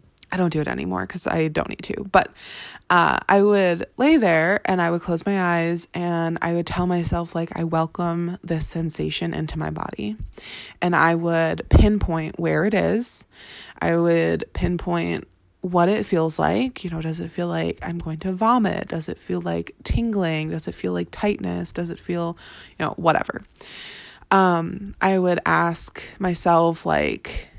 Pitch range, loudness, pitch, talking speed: 155-180 Hz, -22 LUFS, 170 Hz, 175 wpm